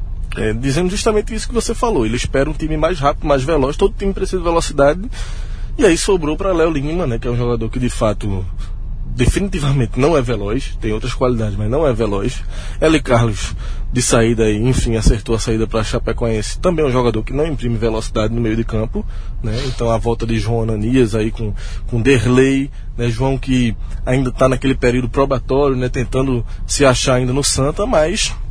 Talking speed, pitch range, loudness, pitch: 200 wpm, 110-140 Hz, -17 LUFS, 125 Hz